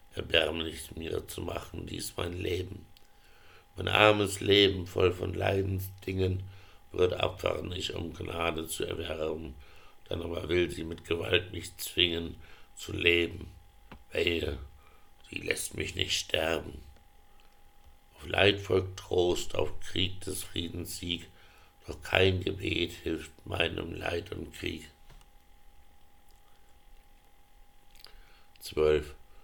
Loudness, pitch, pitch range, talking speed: -31 LUFS, 85 Hz, 80-95 Hz, 110 wpm